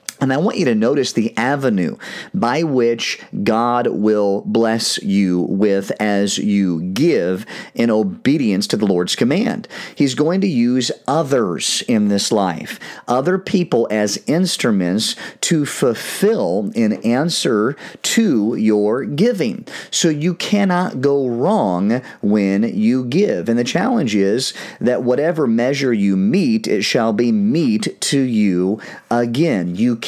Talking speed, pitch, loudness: 135 wpm, 125 Hz, -17 LUFS